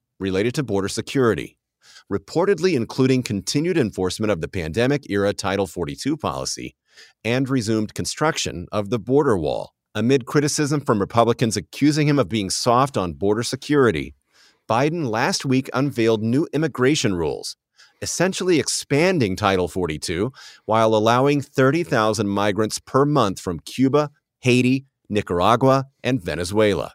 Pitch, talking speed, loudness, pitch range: 120 Hz, 125 wpm, -21 LUFS, 100-140 Hz